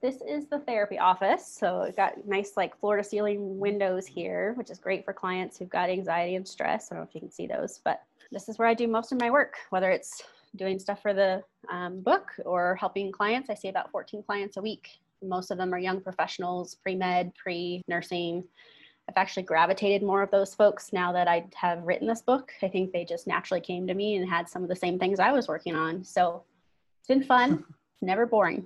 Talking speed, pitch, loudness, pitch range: 230 wpm, 190 Hz, -28 LUFS, 180-210 Hz